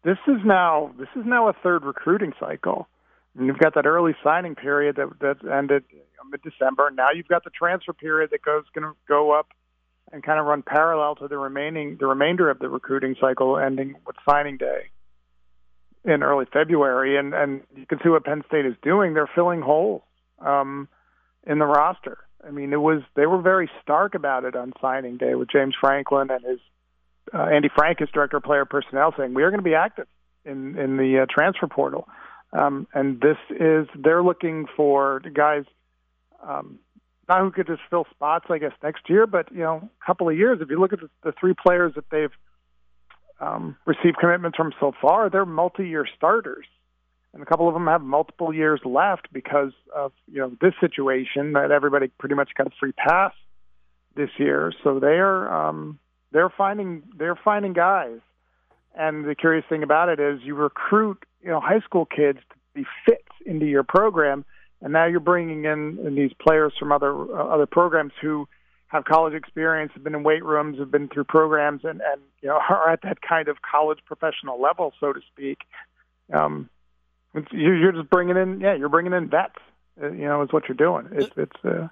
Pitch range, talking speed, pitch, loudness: 135-165 Hz, 200 wpm, 150 Hz, -22 LUFS